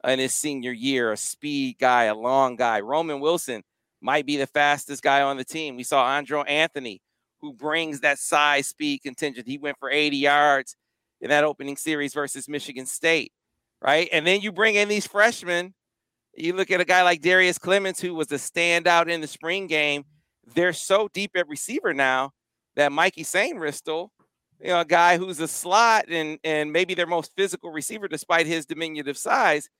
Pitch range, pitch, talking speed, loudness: 145-180 Hz, 155 Hz, 190 wpm, -23 LUFS